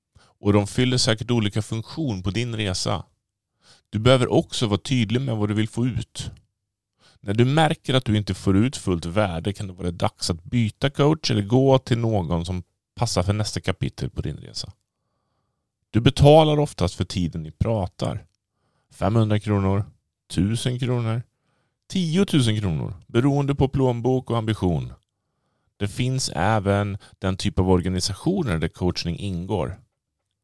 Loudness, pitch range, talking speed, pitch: -23 LUFS, 95-125 Hz, 155 wpm, 110 Hz